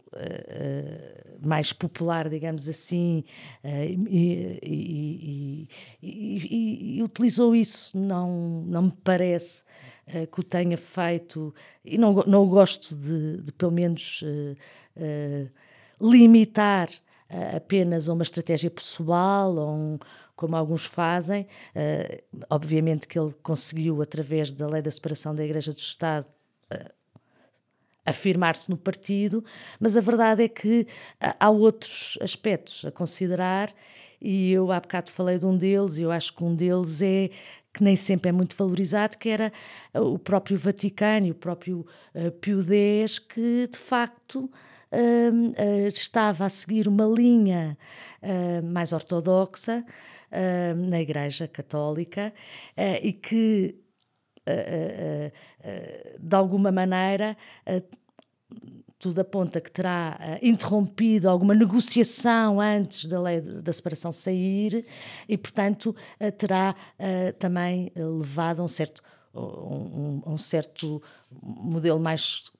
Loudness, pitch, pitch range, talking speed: -25 LUFS, 180 Hz, 160-205 Hz, 135 wpm